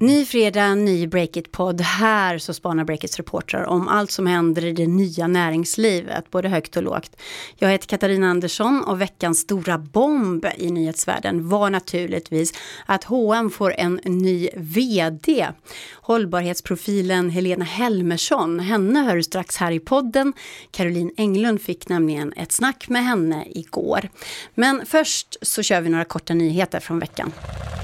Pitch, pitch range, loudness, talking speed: 180 Hz, 170-215 Hz, -21 LUFS, 145 wpm